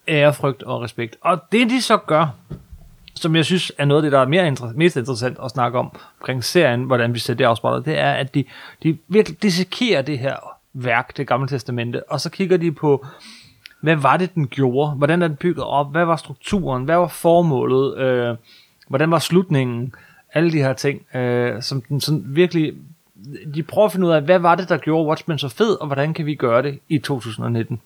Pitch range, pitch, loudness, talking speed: 130-170 Hz, 150 Hz, -19 LUFS, 210 wpm